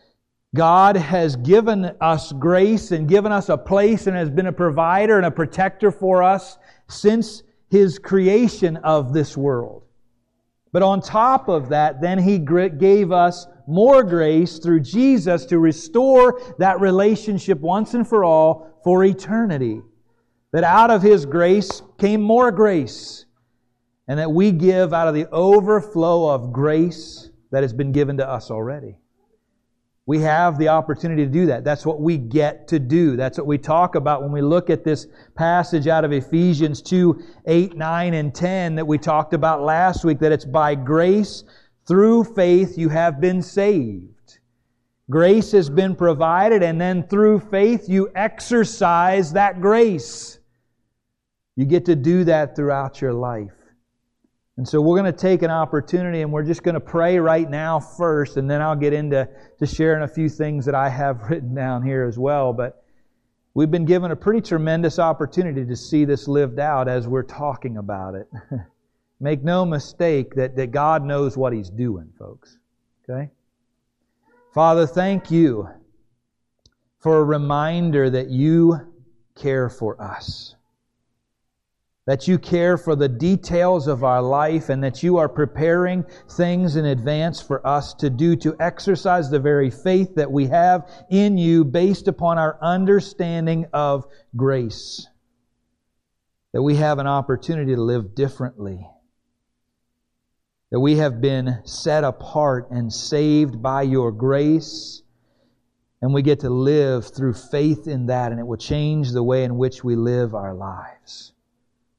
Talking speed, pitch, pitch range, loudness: 160 wpm, 155 Hz, 130-175 Hz, -18 LUFS